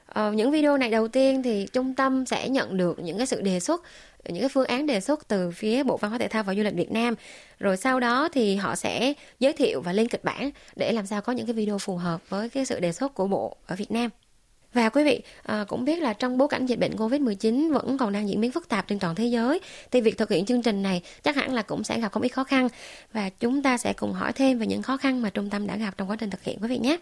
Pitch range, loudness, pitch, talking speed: 205-265 Hz, -26 LUFS, 235 Hz, 285 wpm